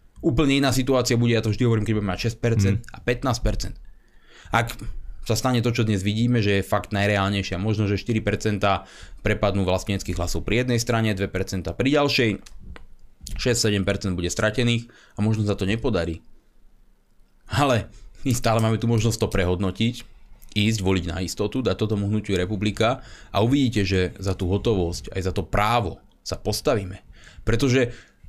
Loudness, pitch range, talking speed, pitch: -23 LUFS, 95-115 Hz, 155 wpm, 105 Hz